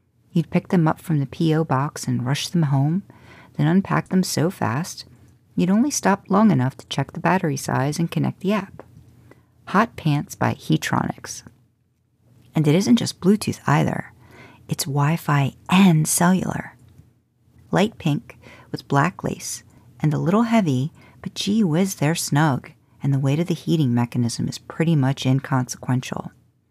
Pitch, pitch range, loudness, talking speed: 145 Hz, 125-170 Hz, -21 LUFS, 160 wpm